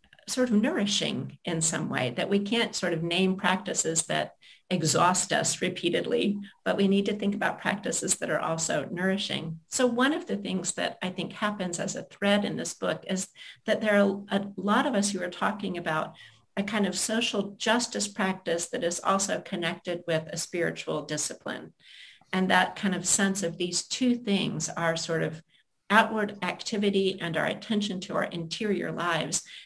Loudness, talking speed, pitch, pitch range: -28 LUFS, 180 wpm, 190 Hz, 175-210 Hz